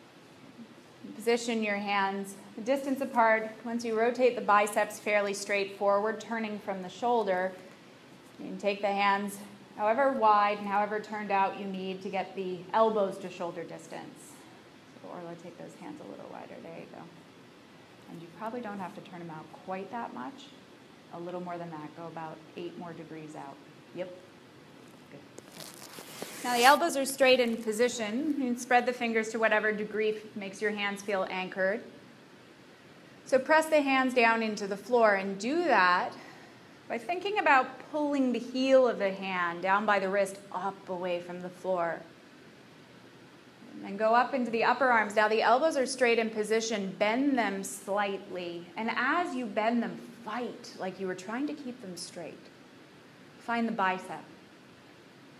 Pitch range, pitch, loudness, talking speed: 190-240 Hz, 210 Hz, -29 LUFS, 170 wpm